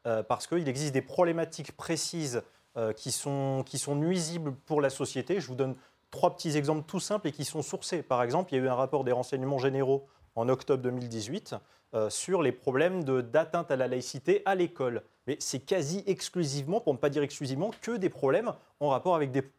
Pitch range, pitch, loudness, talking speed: 130-170 Hz, 145 Hz, -31 LUFS, 200 wpm